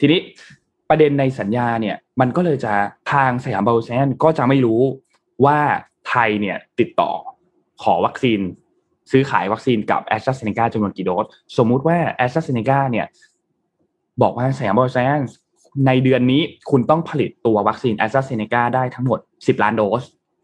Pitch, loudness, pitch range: 130 Hz, -18 LUFS, 115-135 Hz